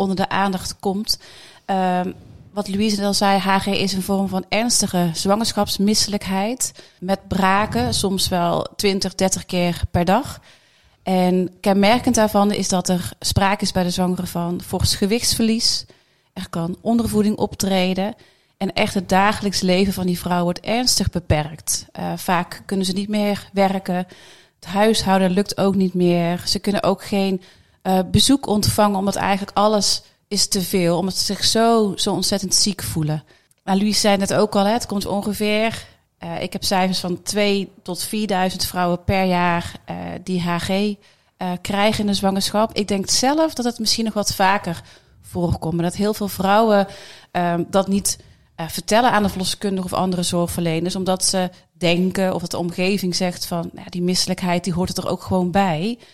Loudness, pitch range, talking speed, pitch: -20 LUFS, 180-205 Hz, 175 wpm, 195 Hz